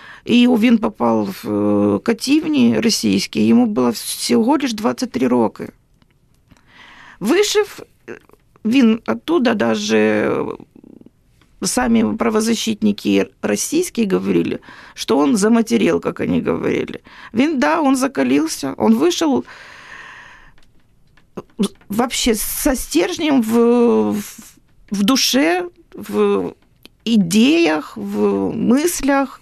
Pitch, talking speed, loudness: 230 Hz, 90 wpm, -17 LUFS